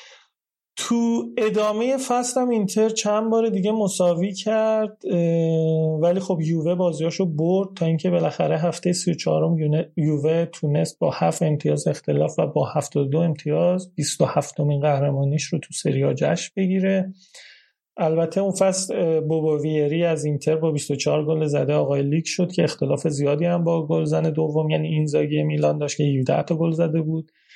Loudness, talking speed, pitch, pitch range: -22 LUFS, 155 wpm, 165 Hz, 150-185 Hz